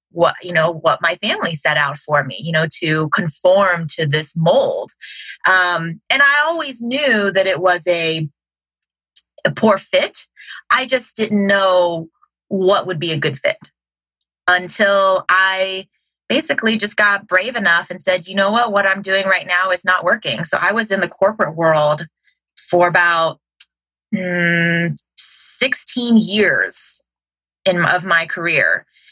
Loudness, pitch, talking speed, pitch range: -16 LUFS, 180 Hz, 155 wpm, 165-200 Hz